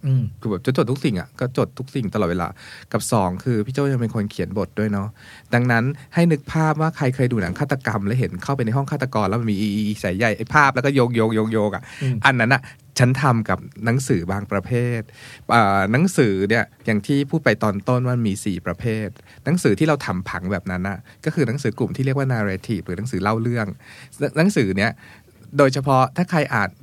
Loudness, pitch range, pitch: -21 LUFS, 105-135 Hz, 115 Hz